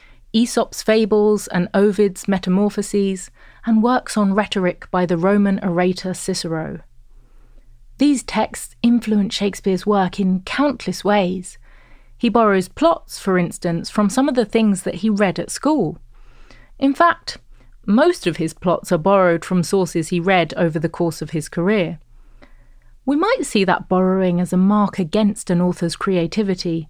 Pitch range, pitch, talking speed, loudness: 180-215 Hz, 195 Hz, 150 wpm, -18 LUFS